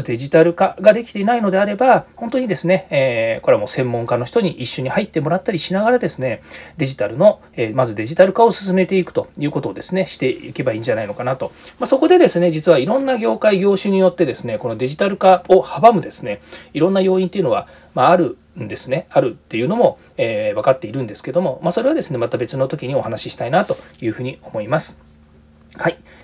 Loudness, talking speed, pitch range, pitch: -17 LUFS, 485 characters per minute, 135-200 Hz, 175 Hz